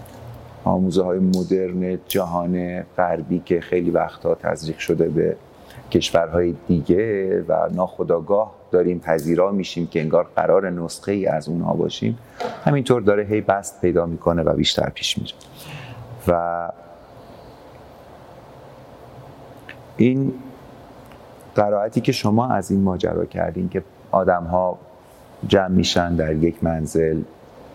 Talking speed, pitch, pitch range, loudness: 115 wpm, 90 Hz, 85-115 Hz, -21 LUFS